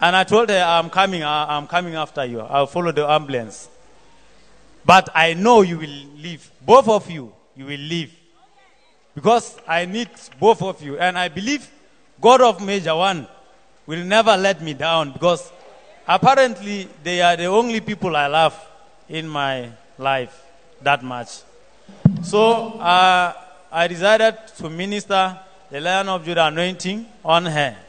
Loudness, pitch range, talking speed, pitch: -18 LUFS, 155-195 Hz, 155 wpm, 170 Hz